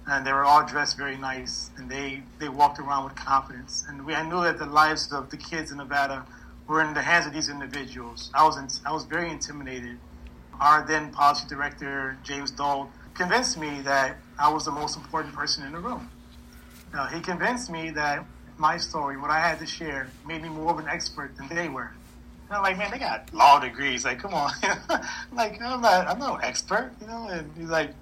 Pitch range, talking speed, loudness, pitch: 135-165 Hz, 215 wpm, -26 LUFS, 145 Hz